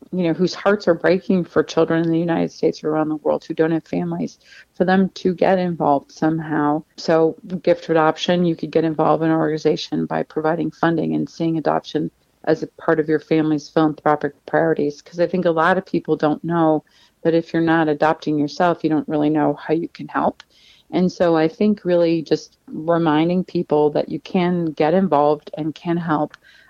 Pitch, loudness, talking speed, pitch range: 160 Hz, -19 LUFS, 200 wpm, 155-175 Hz